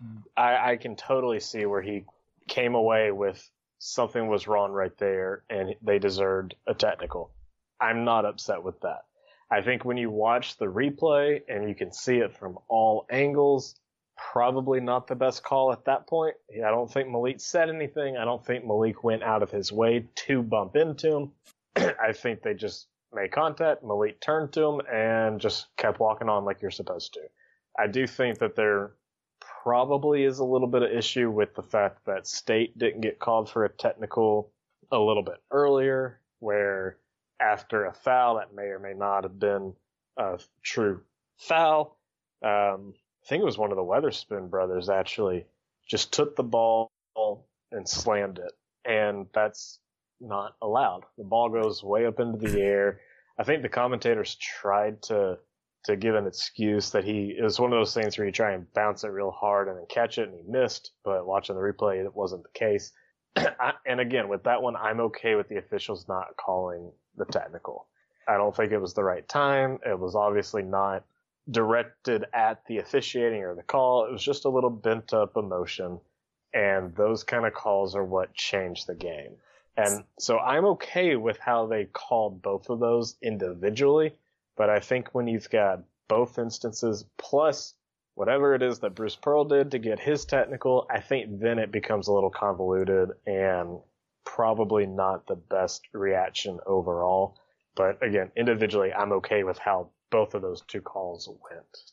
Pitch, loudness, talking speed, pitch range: 110 Hz, -27 LUFS, 180 wpm, 100-130 Hz